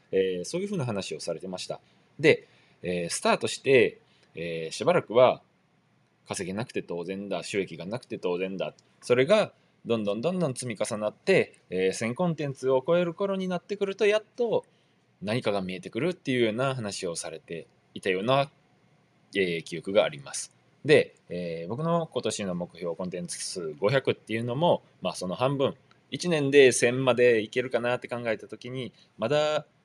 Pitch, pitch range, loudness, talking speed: 125 Hz, 95-160 Hz, -27 LUFS, 340 characters per minute